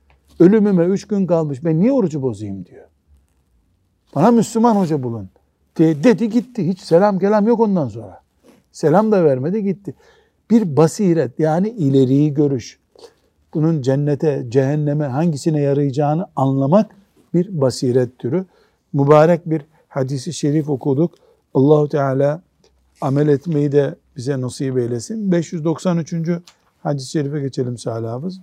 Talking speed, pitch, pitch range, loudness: 120 wpm, 155 Hz, 135-180 Hz, -17 LUFS